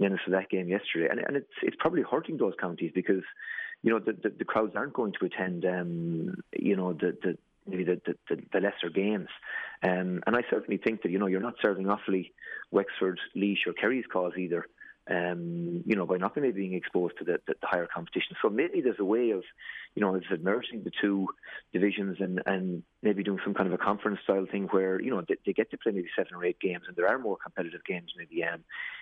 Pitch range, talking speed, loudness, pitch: 90-100 Hz, 235 wpm, -31 LUFS, 95 Hz